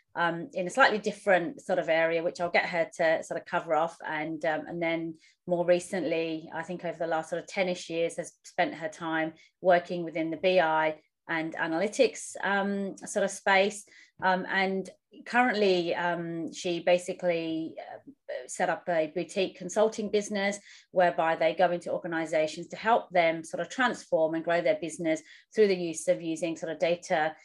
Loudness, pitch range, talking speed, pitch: -29 LUFS, 165-190 Hz, 175 wpm, 175 Hz